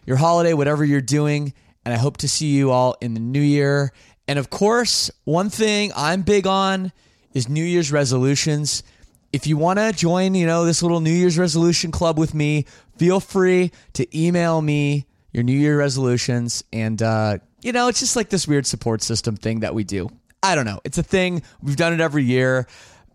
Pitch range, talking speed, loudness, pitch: 125-170 Hz, 200 wpm, -20 LUFS, 145 Hz